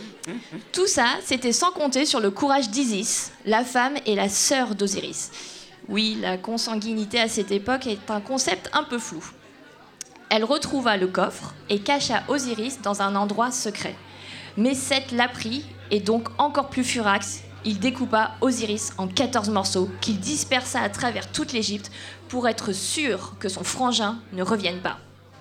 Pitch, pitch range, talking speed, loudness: 225 Hz, 205-255 Hz, 160 wpm, -24 LUFS